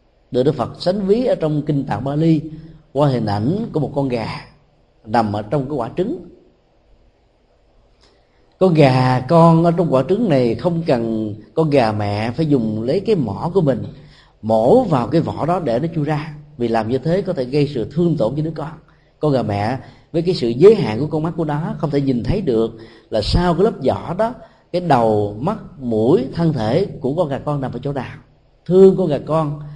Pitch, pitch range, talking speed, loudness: 145 Hz, 125-165 Hz, 220 wpm, -18 LUFS